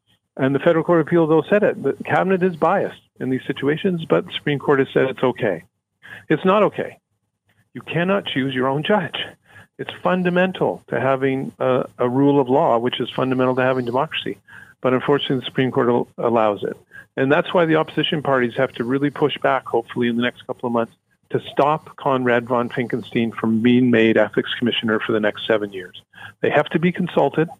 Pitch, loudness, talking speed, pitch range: 130 Hz, -20 LUFS, 200 wpm, 120-155 Hz